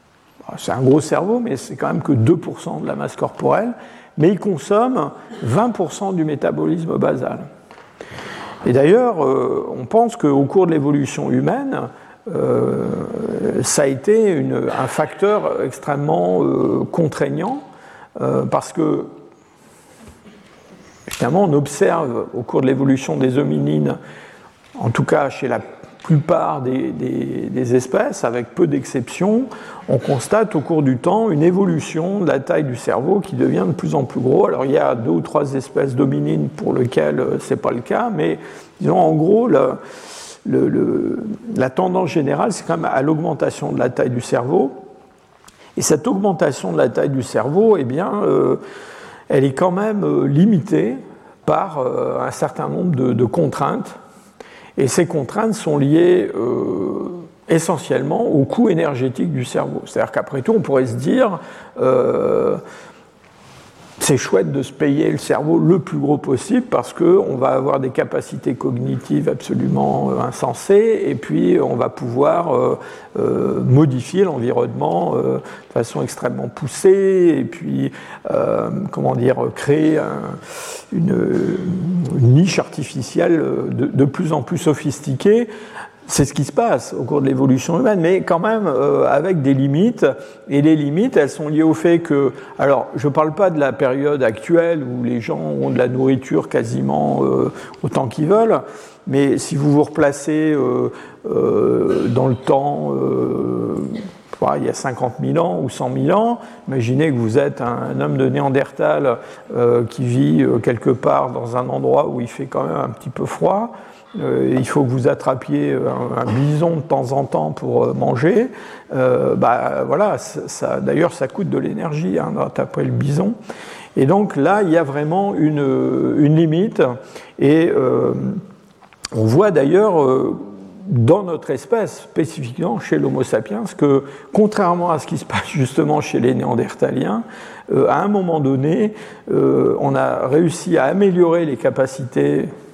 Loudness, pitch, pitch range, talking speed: -17 LUFS, 155 Hz, 135-205 Hz, 155 wpm